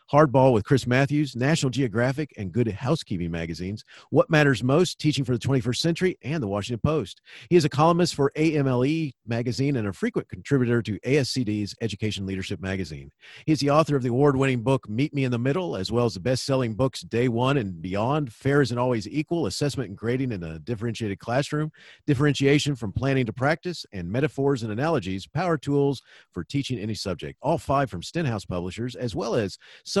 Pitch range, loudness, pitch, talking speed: 110-145 Hz, -25 LUFS, 130 Hz, 195 wpm